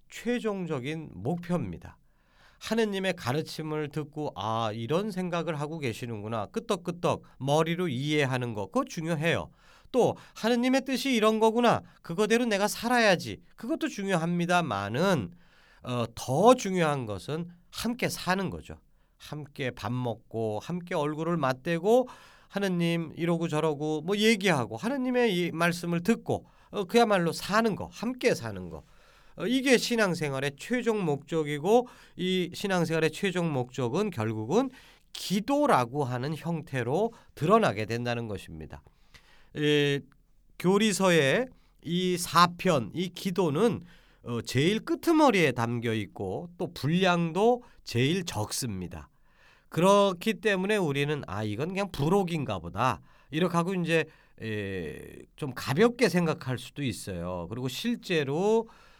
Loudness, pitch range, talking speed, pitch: -28 LUFS, 130-200 Hz, 275 characters per minute, 170 Hz